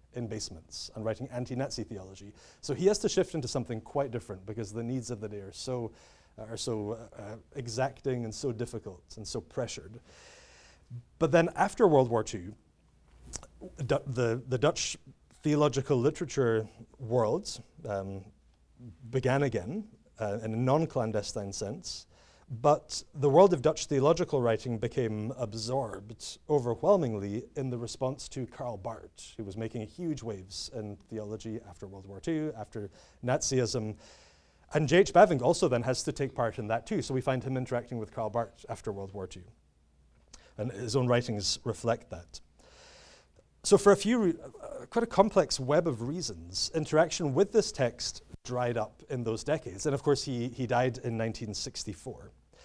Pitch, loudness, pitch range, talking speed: 120 Hz, -31 LUFS, 105-140 Hz, 165 wpm